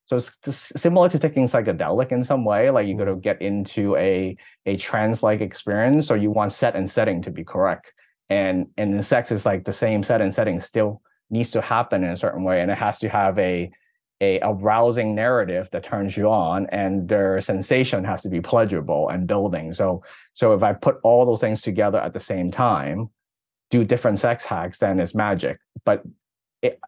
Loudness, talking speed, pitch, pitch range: -21 LUFS, 210 wpm, 110 Hz, 100-125 Hz